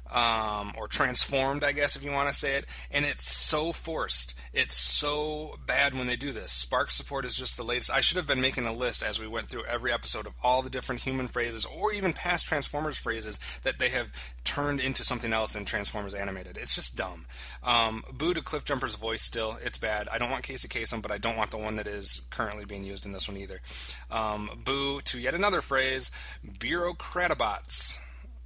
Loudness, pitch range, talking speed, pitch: -26 LUFS, 100-130 Hz, 215 wpm, 110 Hz